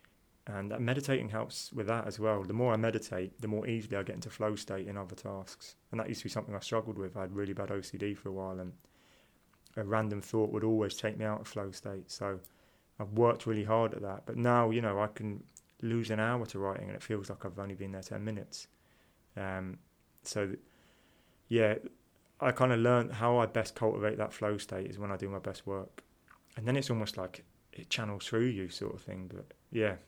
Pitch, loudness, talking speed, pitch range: 105 Hz, -35 LUFS, 230 wpm, 100-115 Hz